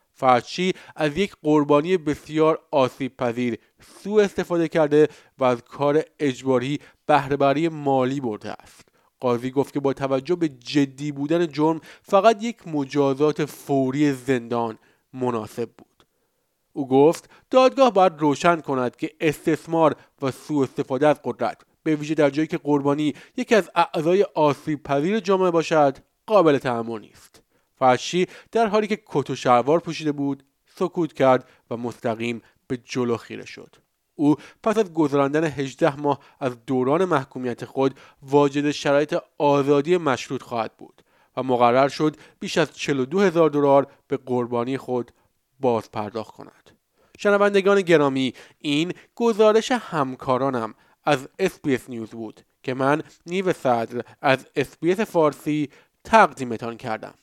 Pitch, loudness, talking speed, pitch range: 145 Hz, -22 LUFS, 135 wpm, 130-165 Hz